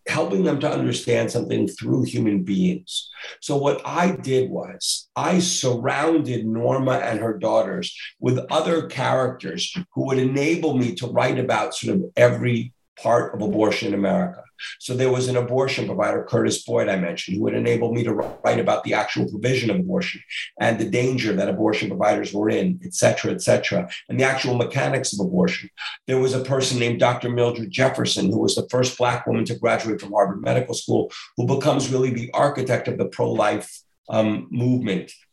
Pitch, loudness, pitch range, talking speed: 125 Hz, -22 LUFS, 115-135 Hz, 180 wpm